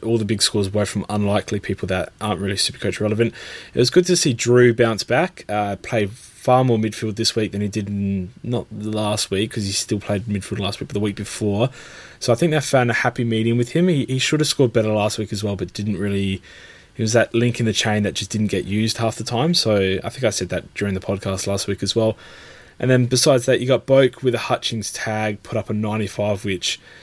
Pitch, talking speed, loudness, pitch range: 110 Hz, 255 wpm, -20 LUFS, 100-120 Hz